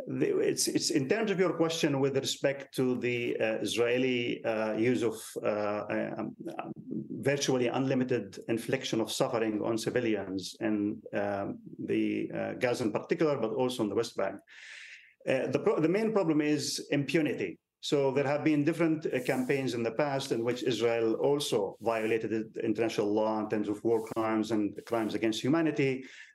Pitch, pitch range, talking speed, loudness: 120 Hz, 110-145 Hz, 165 wpm, -31 LUFS